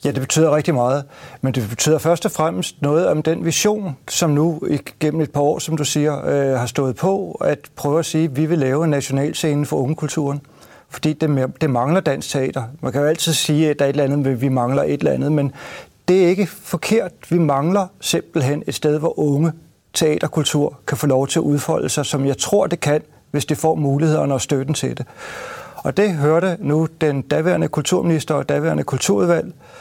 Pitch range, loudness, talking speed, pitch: 140-165 Hz, -19 LUFS, 215 wpm, 150 Hz